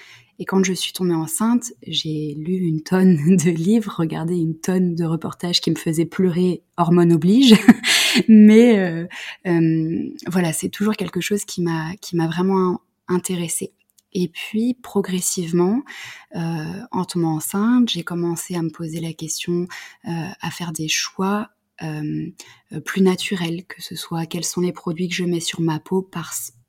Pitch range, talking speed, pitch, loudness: 165-190 Hz, 165 wpm, 175 Hz, -19 LUFS